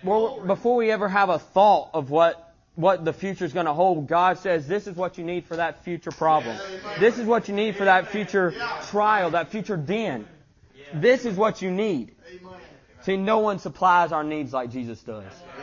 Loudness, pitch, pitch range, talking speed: -23 LUFS, 185 Hz, 165-205 Hz, 205 wpm